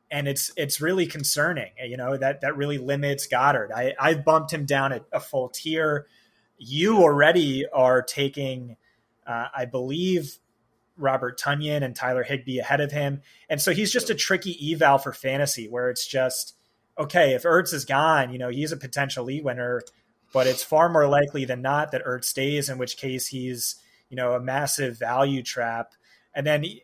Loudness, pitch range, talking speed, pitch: -24 LUFS, 125-150 Hz, 185 wpm, 140 Hz